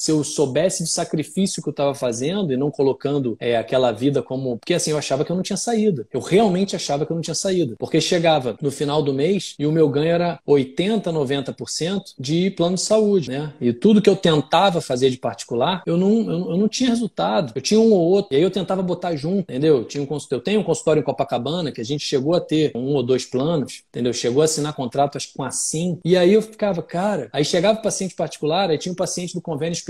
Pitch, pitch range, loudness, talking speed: 160 Hz, 140-185 Hz, -20 LUFS, 240 wpm